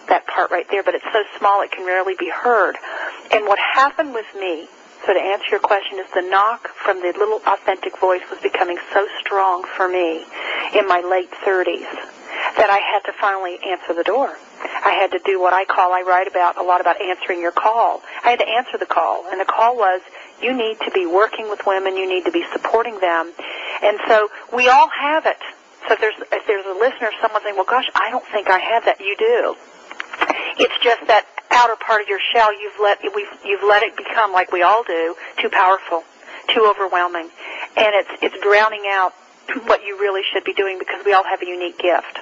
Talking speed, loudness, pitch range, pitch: 220 wpm, -18 LUFS, 185-225 Hz, 200 Hz